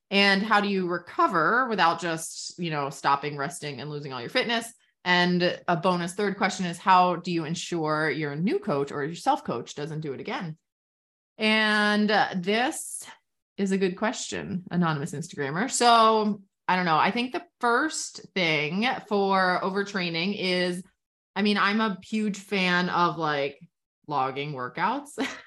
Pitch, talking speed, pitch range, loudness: 180 Hz, 160 wpm, 160-210 Hz, -25 LUFS